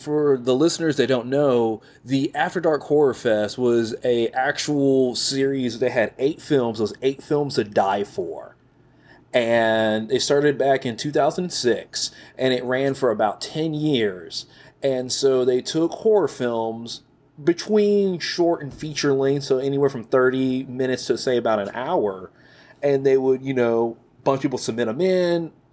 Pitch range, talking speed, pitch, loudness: 125-150 Hz, 165 wpm, 135 Hz, -22 LUFS